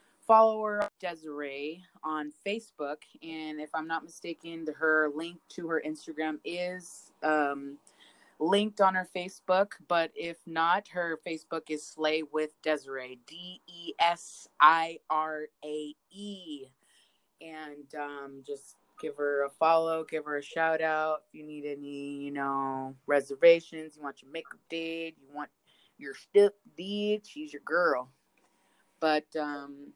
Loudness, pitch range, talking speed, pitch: -30 LUFS, 145-170 Hz, 140 wpm, 155 Hz